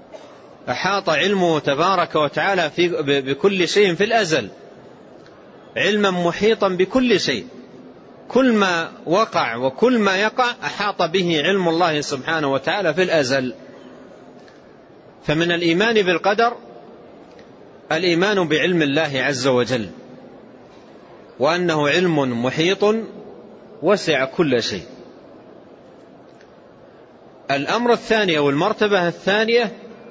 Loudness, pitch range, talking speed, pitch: -18 LUFS, 155-210 Hz, 90 wpm, 180 Hz